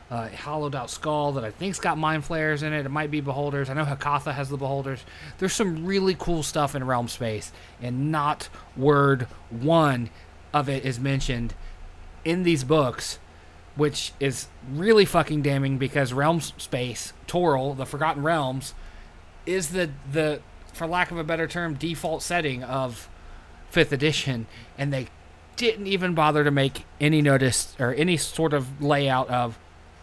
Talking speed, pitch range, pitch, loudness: 165 wpm, 120-155 Hz, 140 Hz, -25 LUFS